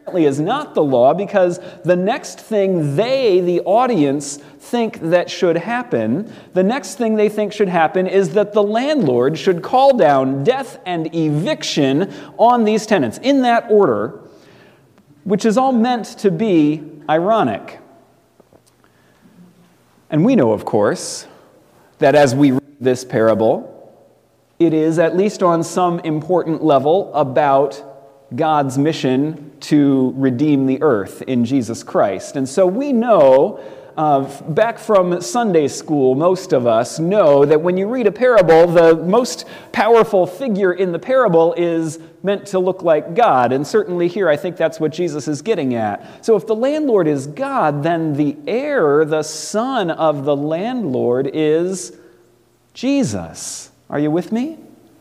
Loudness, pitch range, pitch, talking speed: -16 LUFS, 145-210 Hz, 170 Hz, 150 wpm